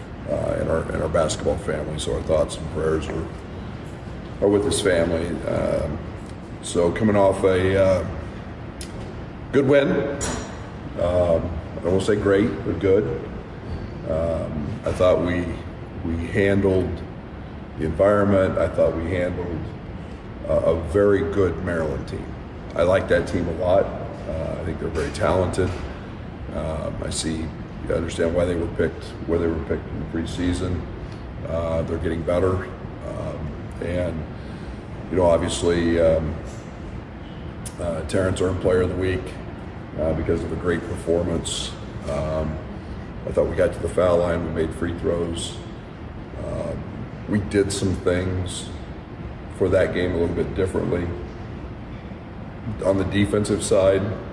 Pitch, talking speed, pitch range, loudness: 90 Hz, 140 wpm, 80-95 Hz, -23 LUFS